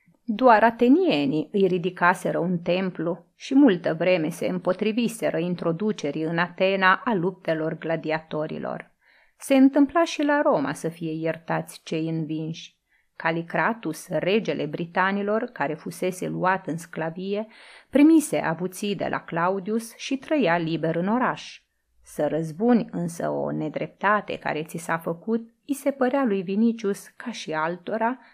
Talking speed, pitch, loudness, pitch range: 130 wpm, 185 Hz, -24 LUFS, 160-230 Hz